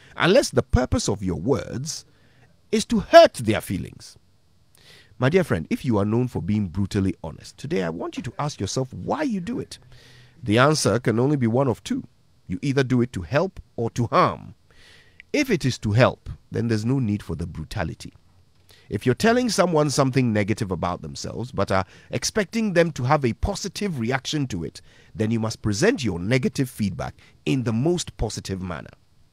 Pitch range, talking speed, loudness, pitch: 105-145 Hz, 190 wpm, -23 LUFS, 120 Hz